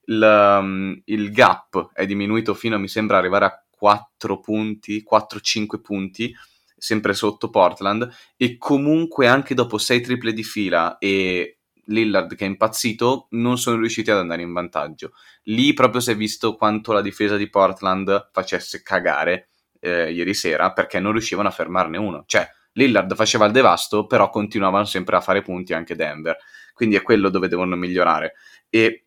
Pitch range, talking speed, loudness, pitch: 100-115 Hz, 160 wpm, -19 LUFS, 105 Hz